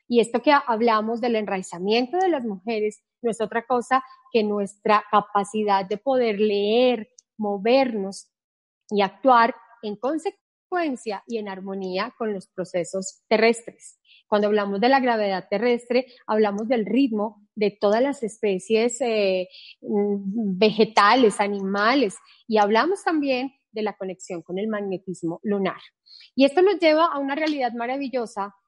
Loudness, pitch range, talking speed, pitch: -23 LUFS, 205-250 Hz, 135 wpm, 220 Hz